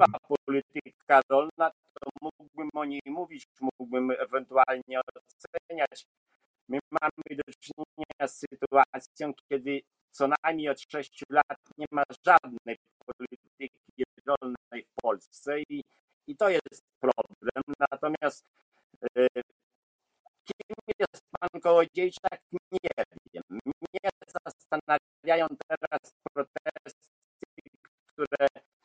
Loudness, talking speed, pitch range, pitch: -30 LUFS, 100 wpm, 135-160 Hz, 145 Hz